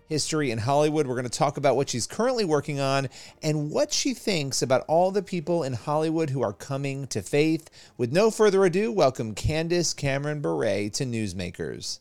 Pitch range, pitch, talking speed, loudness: 130-170 Hz, 150 Hz, 190 wpm, -25 LUFS